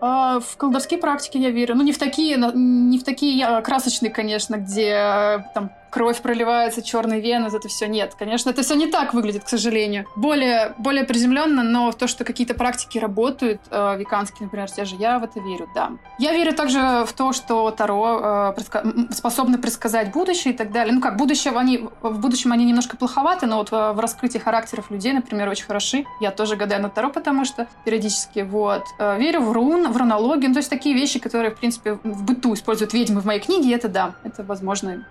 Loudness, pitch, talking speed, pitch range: -21 LUFS, 235 Hz, 205 wpm, 215-255 Hz